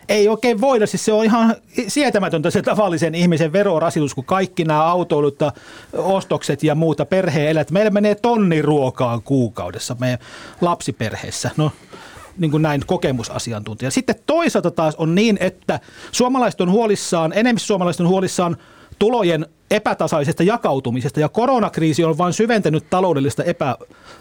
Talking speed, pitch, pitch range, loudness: 140 wpm, 170 Hz, 150-205 Hz, -18 LUFS